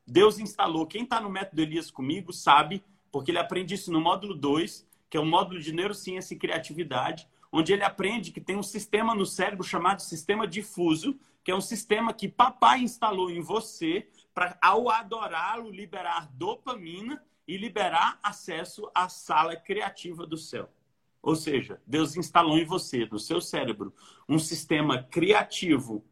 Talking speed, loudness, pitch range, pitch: 160 wpm, -28 LUFS, 165-205 Hz, 185 Hz